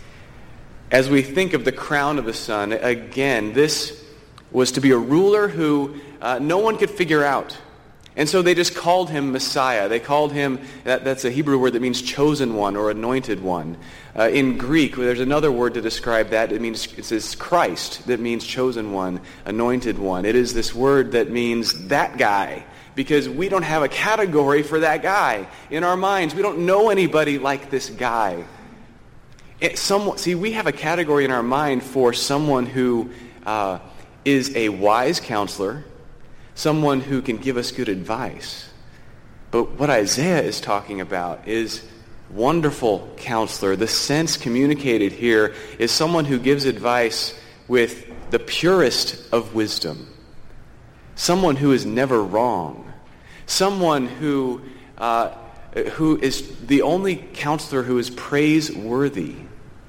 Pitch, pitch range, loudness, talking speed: 130 Hz, 115-150 Hz, -20 LUFS, 155 wpm